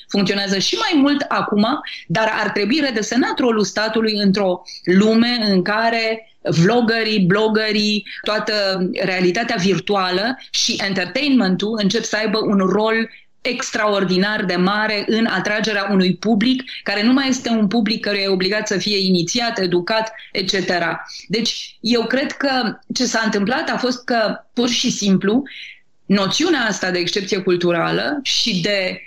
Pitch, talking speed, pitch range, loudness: 215 Hz, 140 wpm, 195-235 Hz, -18 LUFS